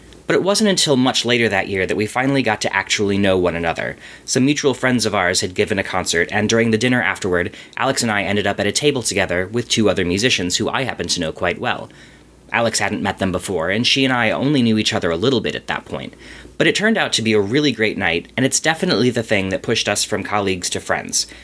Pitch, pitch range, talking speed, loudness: 110 Hz, 100-130 Hz, 255 wpm, -18 LUFS